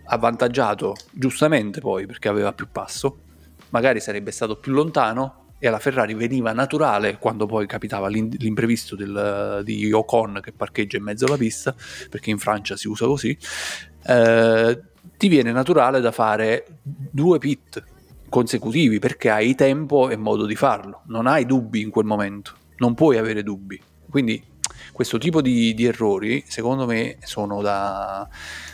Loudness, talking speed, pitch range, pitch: -21 LUFS, 150 wpm, 105-130 Hz, 115 Hz